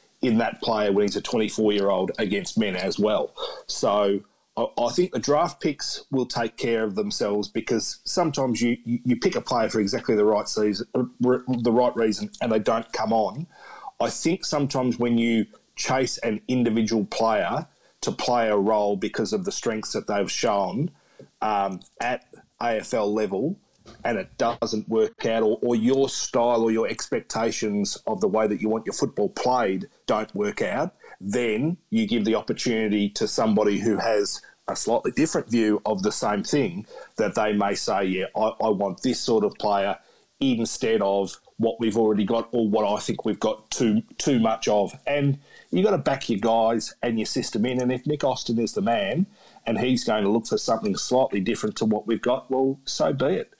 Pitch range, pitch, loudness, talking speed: 105-125 Hz, 115 Hz, -24 LUFS, 195 wpm